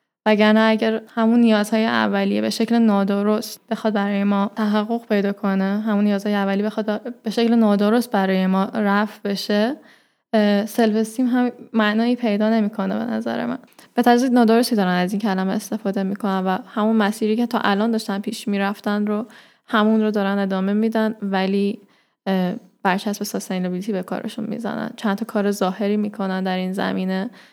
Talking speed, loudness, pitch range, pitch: 155 wpm, -20 LUFS, 200-225 Hz, 210 Hz